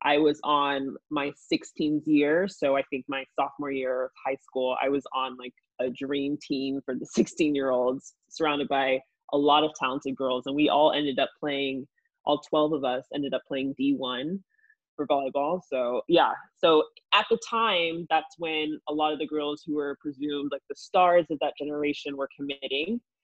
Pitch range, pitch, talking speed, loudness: 135-155 Hz, 145 Hz, 190 wpm, -27 LUFS